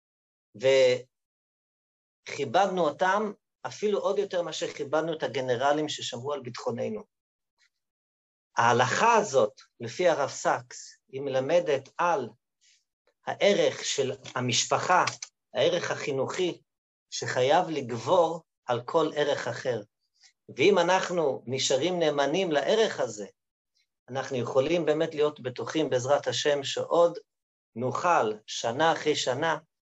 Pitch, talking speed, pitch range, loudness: 155 Hz, 100 wpm, 135-190 Hz, -27 LUFS